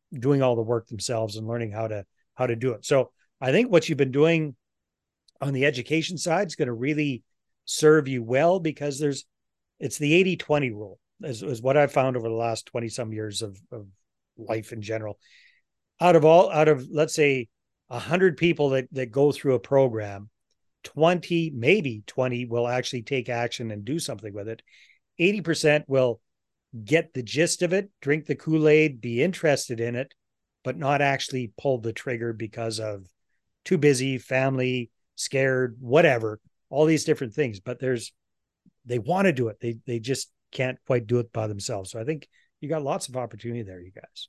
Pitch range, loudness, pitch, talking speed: 115-150 Hz, -25 LUFS, 130 Hz, 185 wpm